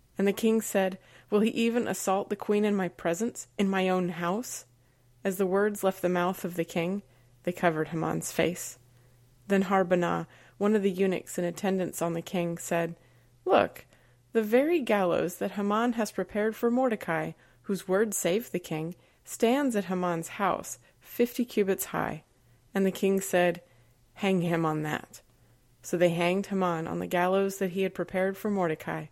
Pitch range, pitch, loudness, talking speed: 165-200 Hz, 180 Hz, -29 LUFS, 175 wpm